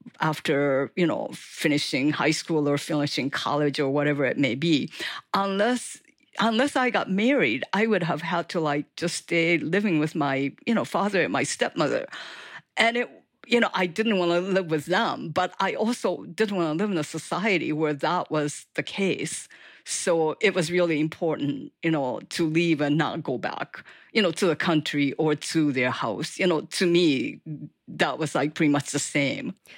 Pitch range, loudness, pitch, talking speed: 150-195 Hz, -25 LUFS, 165 Hz, 190 wpm